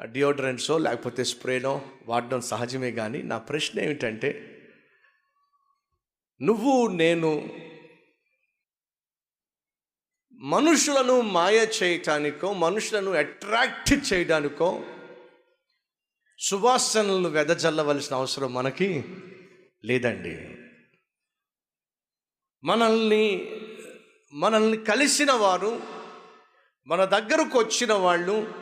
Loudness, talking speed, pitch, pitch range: -24 LUFS, 65 wpm, 190 Hz, 145-240 Hz